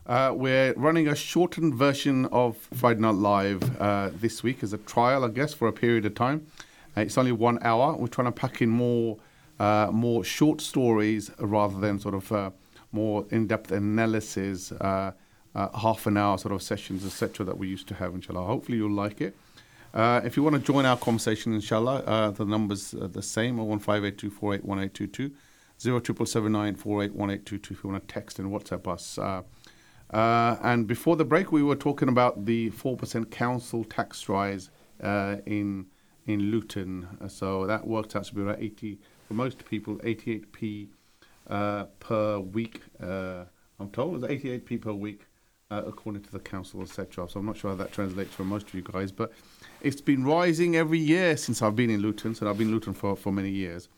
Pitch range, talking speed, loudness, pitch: 100-120 Hz, 210 wpm, -28 LUFS, 110 Hz